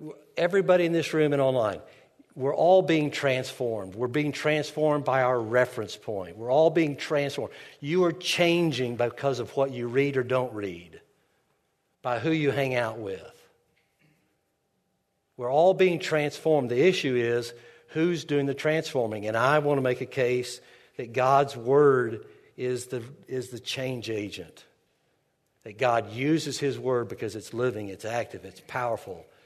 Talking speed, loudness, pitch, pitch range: 155 wpm, -26 LUFS, 135 Hz, 120-155 Hz